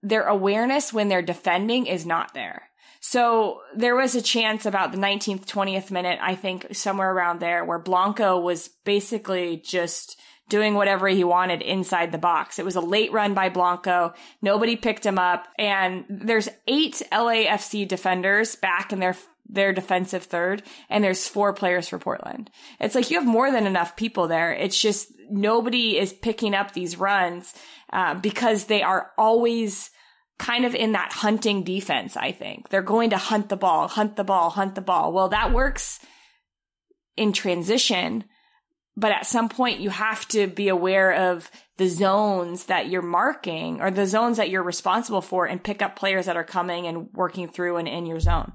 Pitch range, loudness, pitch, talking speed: 180-220 Hz, -23 LUFS, 195 Hz, 180 wpm